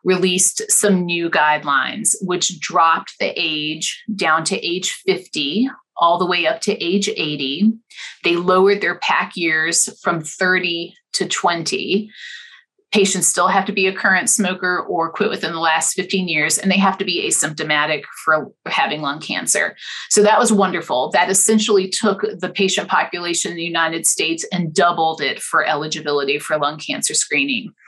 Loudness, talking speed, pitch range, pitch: -17 LUFS, 165 wpm, 165-205 Hz, 185 Hz